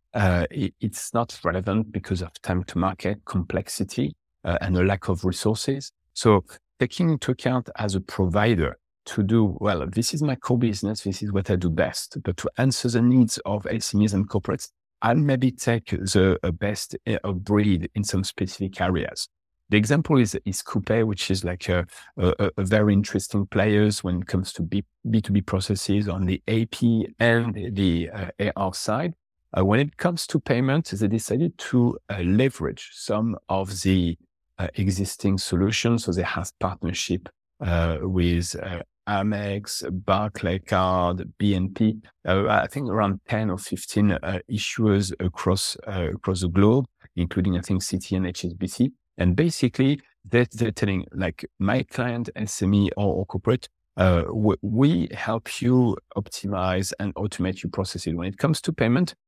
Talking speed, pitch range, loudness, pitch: 165 wpm, 95-110 Hz, -24 LUFS, 100 Hz